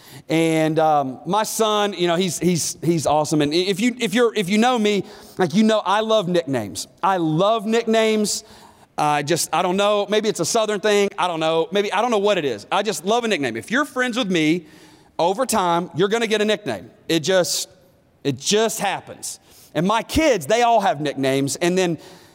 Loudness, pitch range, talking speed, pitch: -20 LUFS, 160-215 Hz, 235 wpm, 185 Hz